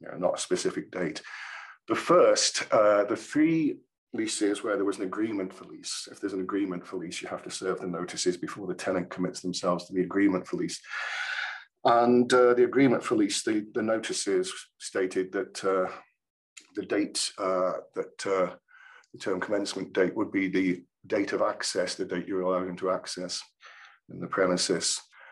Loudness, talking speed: -28 LUFS, 185 wpm